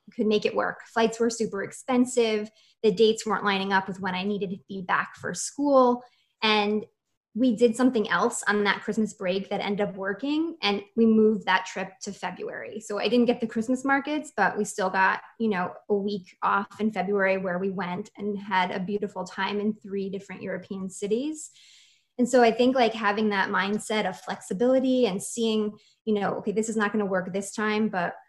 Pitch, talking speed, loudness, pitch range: 210 Hz, 205 wpm, -26 LUFS, 195-230 Hz